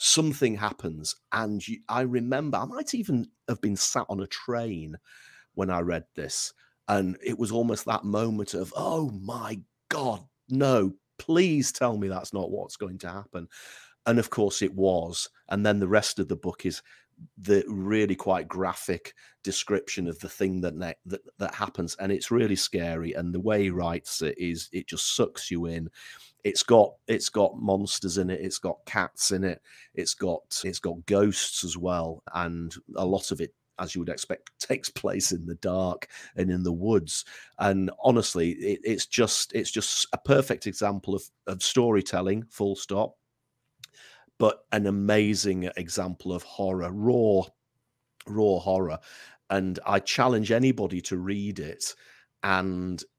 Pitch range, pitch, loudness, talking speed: 90-110 Hz, 100 Hz, -27 LUFS, 170 wpm